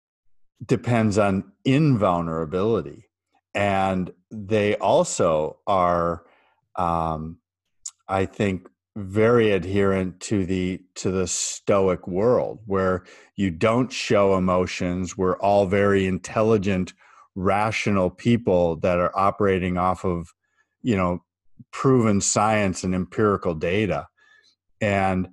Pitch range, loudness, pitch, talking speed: 90-105 Hz, -22 LUFS, 95 Hz, 100 wpm